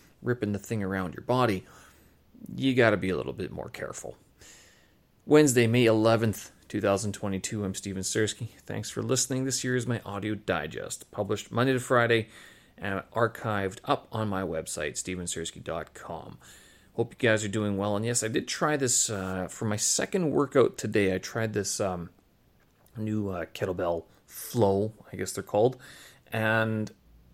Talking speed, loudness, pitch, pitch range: 160 wpm, -28 LUFS, 105 Hz, 95-115 Hz